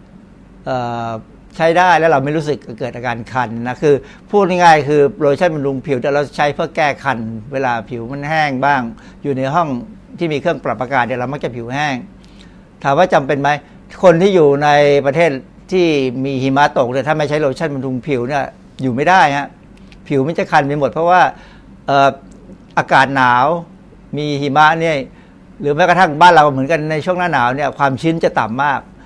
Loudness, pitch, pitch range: -14 LUFS, 145 Hz, 135-165 Hz